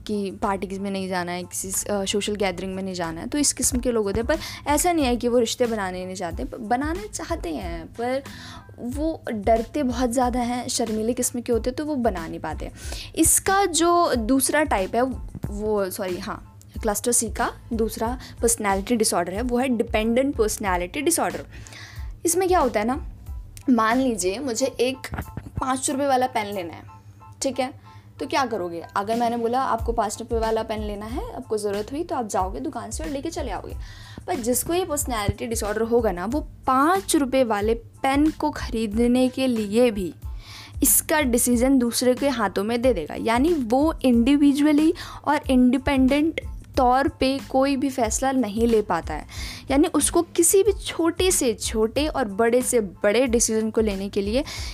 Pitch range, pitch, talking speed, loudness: 215-280 Hz, 245 Hz, 185 wpm, -23 LUFS